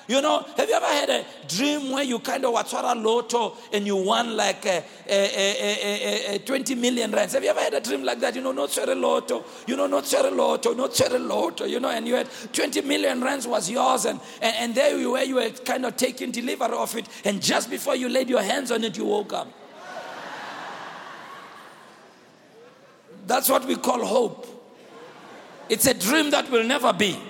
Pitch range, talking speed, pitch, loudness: 220-270 Hz, 215 wpm, 245 Hz, -24 LUFS